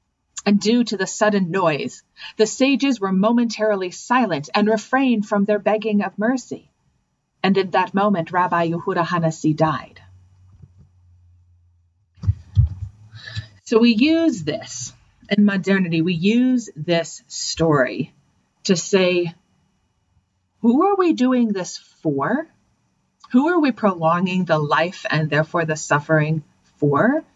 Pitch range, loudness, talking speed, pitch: 150-220 Hz, -19 LUFS, 120 wpm, 185 Hz